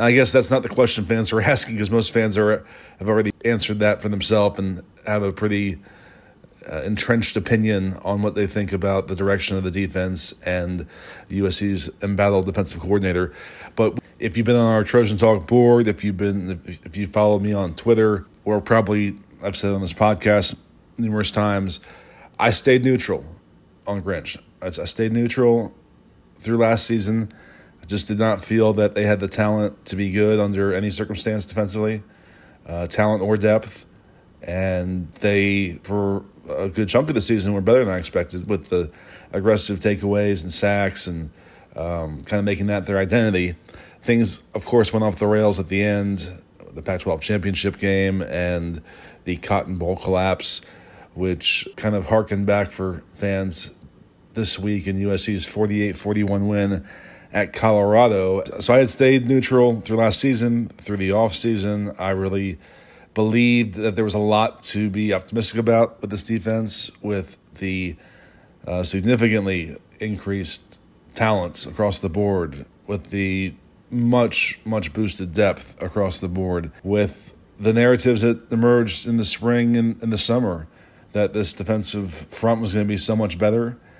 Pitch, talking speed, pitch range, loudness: 105 Hz, 165 wpm, 95-110 Hz, -20 LUFS